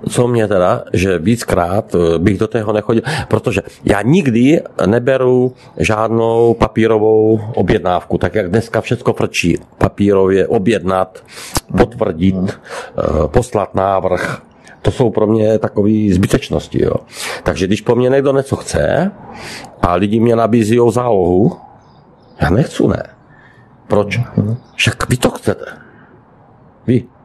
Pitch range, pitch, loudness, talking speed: 100-120 Hz, 110 Hz, -14 LUFS, 120 wpm